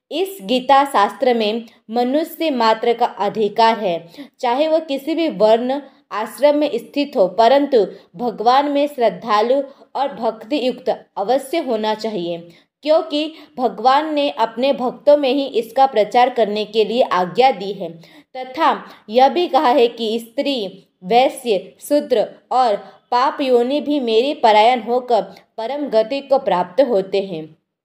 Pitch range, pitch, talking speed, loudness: 215-280 Hz, 245 Hz, 140 wpm, -17 LUFS